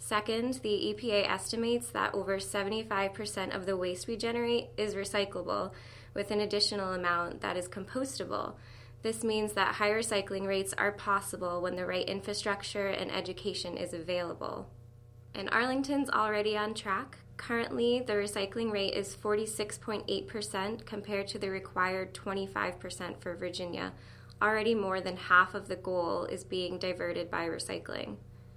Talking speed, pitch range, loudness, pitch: 140 wpm, 180-210 Hz, -33 LUFS, 195 Hz